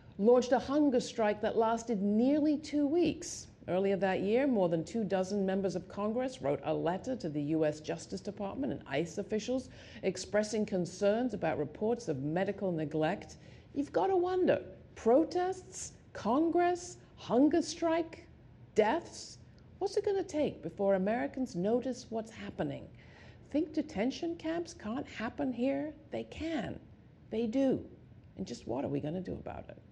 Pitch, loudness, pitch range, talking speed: 230 Hz, -33 LUFS, 190-290 Hz, 150 wpm